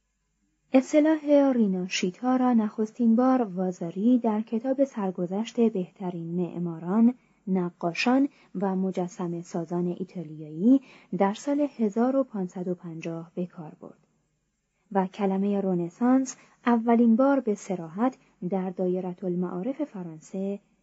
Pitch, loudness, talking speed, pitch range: 195 Hz, -26 LUFS, 95 wpm, 180-240 Hz